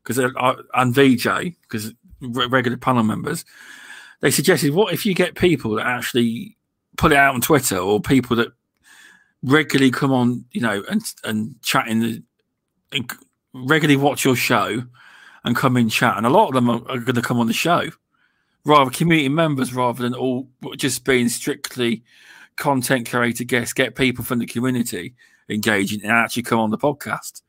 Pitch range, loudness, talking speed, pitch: 120-140 Hz, -19 LUFS, 175 wpm, 125 Hz